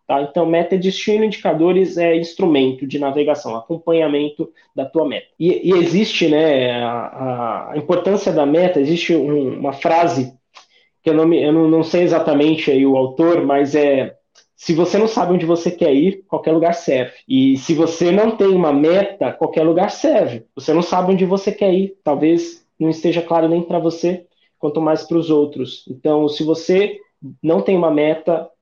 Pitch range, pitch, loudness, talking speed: 150-175 Hz, 165 Hz, -16 LUFS, 180 wpm